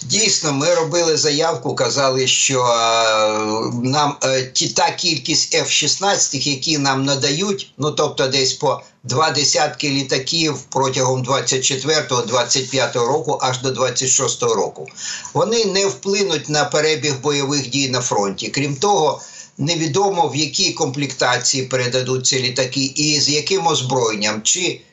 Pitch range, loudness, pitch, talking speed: 130-160 Hz, -17 LUFS, 140 Hz, 125 wpm